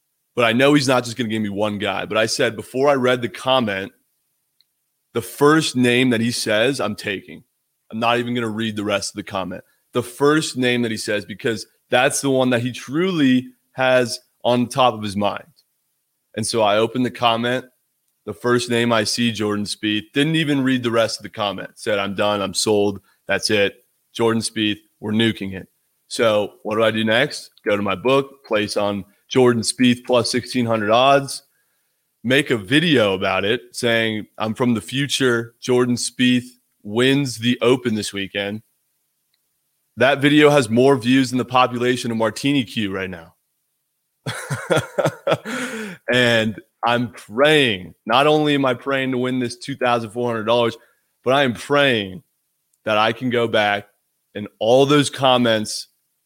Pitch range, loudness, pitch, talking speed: 110-130 Hz, -19 LUFS, 120 Hz, 175 wpm